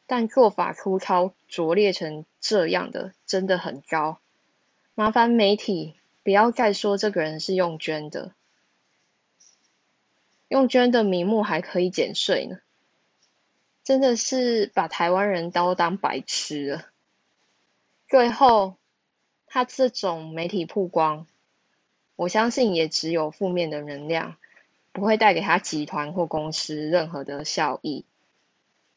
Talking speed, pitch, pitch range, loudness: 180 characters per minute, 180 Hz, 160-215 Hz, -23 LUFS